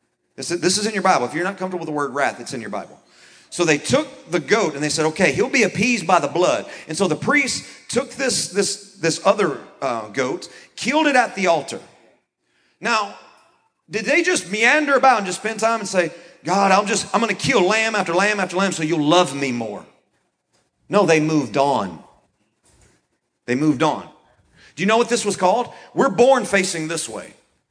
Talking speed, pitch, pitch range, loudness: 205 wpm, 190 Hz, 160-220 Hz, -19 LUFS